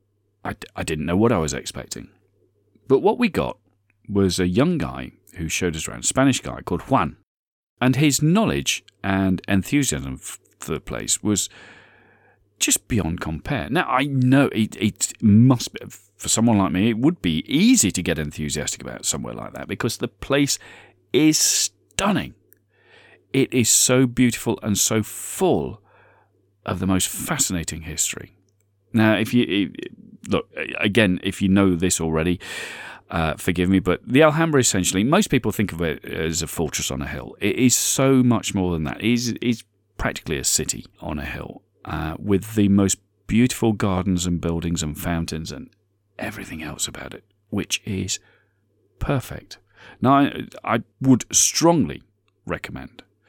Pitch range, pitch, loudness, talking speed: 90-120 Hz, 100 Hz, -21 LUFS, 160 wpm